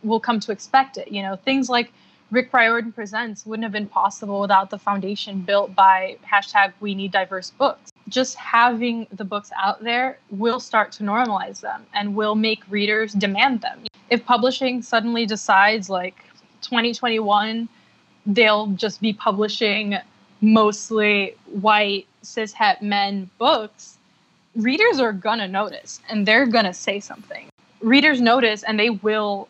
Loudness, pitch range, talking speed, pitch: -20 LUFS, 200-235 Hz, 145 wpm, 215 Hz